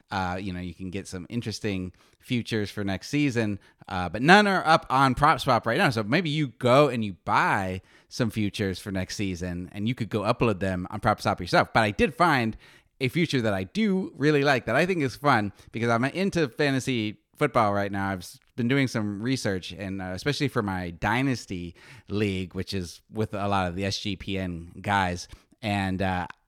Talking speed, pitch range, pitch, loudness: 200 wpm, 95-130 Hz, 105 Hz, -26 LUFS